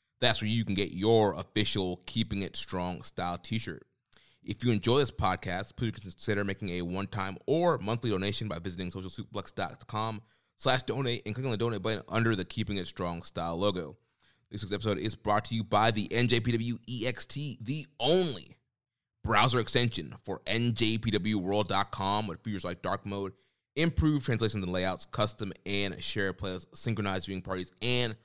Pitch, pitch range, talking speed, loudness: 105 Hz, 95-115 Hz, 160 wpm, -31 LUFS